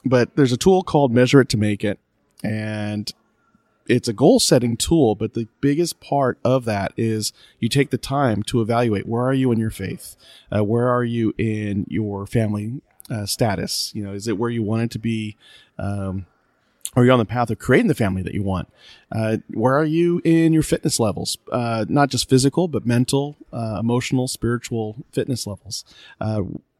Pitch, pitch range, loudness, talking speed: 115 Hz, 105-130 Hz, -20 LUFS, 195 wpm